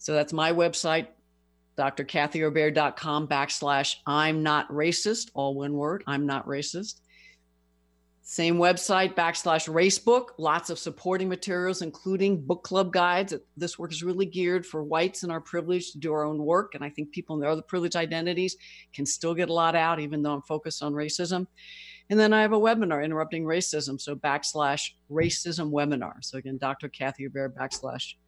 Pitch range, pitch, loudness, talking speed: 145-180 Hz, 160 Hz, -27 LUFS, 165 wpm